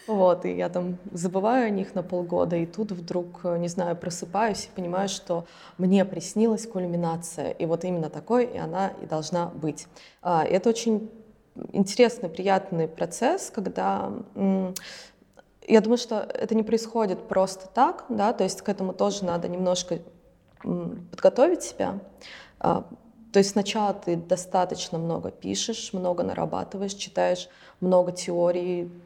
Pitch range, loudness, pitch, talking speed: 175-210 Hz, -26 LUFS, 185 Hz, 140 wpm